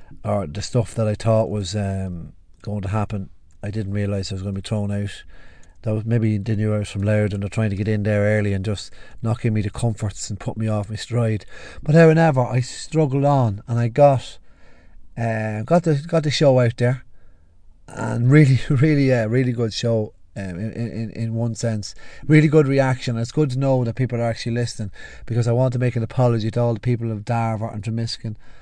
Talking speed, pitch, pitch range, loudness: 225 wpm, 115 Hz, 105-125 Hz, -21 LUFS